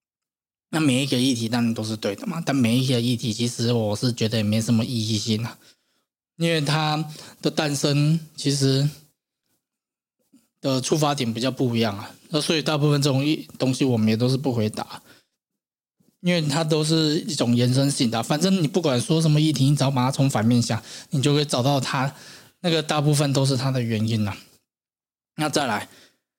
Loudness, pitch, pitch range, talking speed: -22 LUFS, 135 Hz, 120-150 Hz, 275 characters per minute